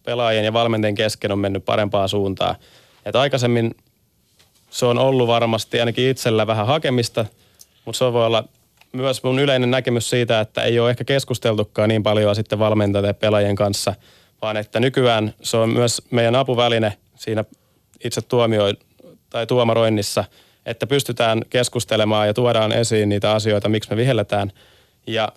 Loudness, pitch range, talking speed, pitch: -19 LUFS, 105-120 Hz, 150 wpm, 115 Hz